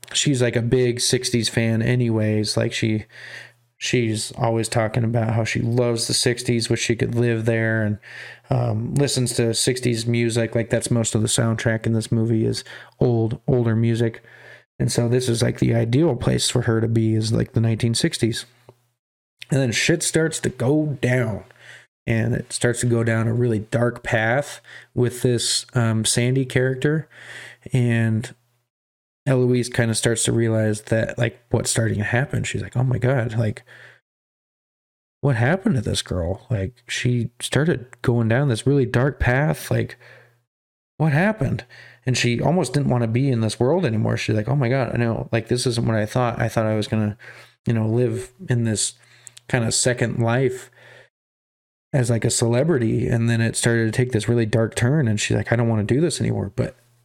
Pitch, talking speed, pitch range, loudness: 120 Hz, 190 wpm, 115-125 Hz, -21 LUFS